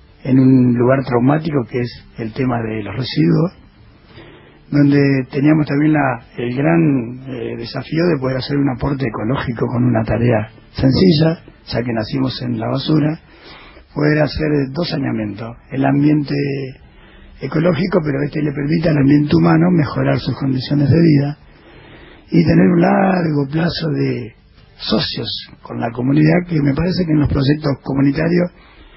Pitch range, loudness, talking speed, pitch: 130-155 Hz, -16 LUFS, 150 wpm, 140 Hz